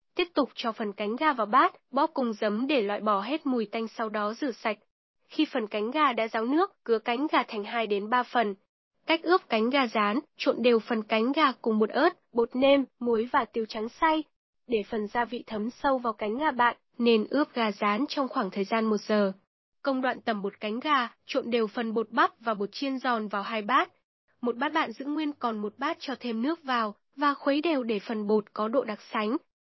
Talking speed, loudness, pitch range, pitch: 235 wpm, -28 LUFS, 220-280 Hz, 240 Hz